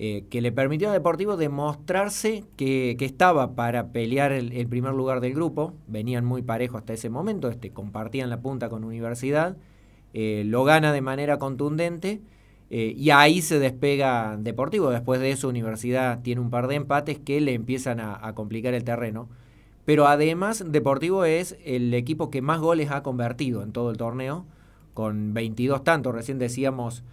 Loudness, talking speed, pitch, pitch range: -25 LUFS, 175 wpm, 130 Hz, 120-150 Hz